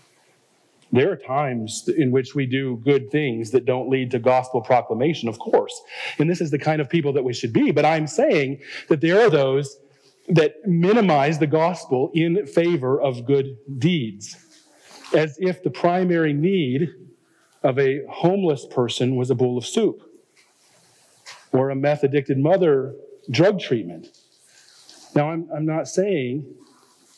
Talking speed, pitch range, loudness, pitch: 155 wpm, 135-170 Hz, -21 LUFS, 145 Hz